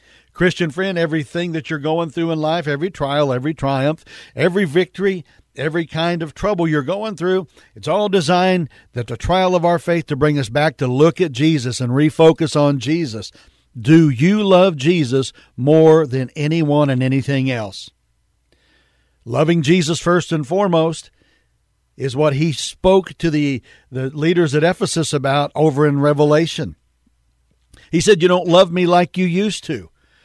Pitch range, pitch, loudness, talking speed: 140-175 Hz, 160 Hz, -17 LUFS, 165 wpm